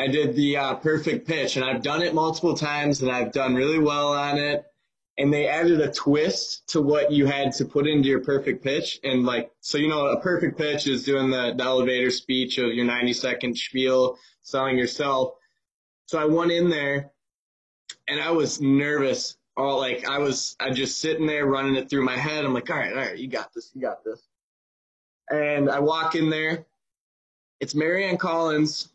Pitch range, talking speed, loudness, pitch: 130-155 Hz, 205 wpm, -24 LUFS, 140 Hz